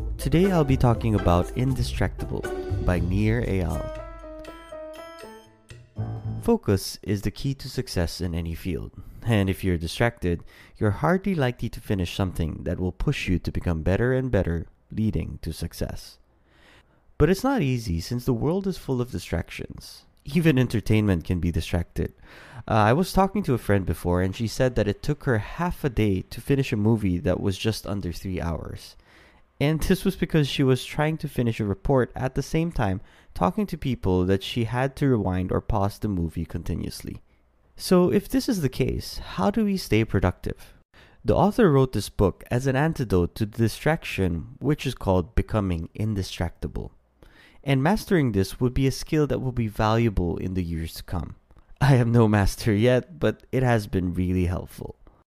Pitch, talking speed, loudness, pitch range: 110 Hz, 180 wpm, -25 LUFS, 90-135 Hz